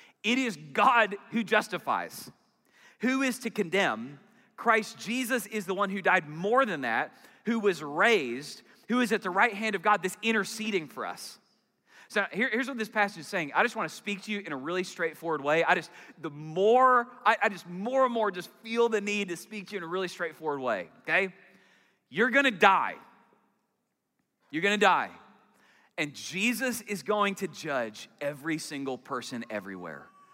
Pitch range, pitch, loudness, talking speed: 180-230 Hz, 205 Hz, -28 LUFS, 185 wpm